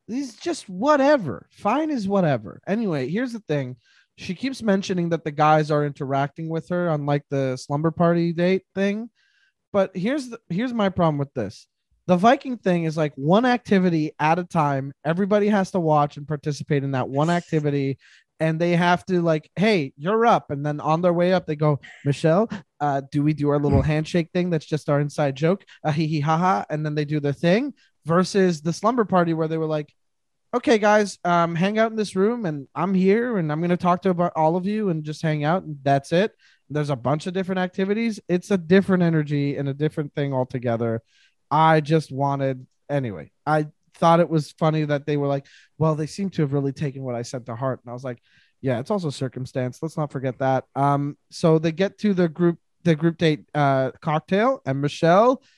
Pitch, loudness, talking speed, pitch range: 160 Hz, -22 LUFS, 215 wpm, 145-190 Hz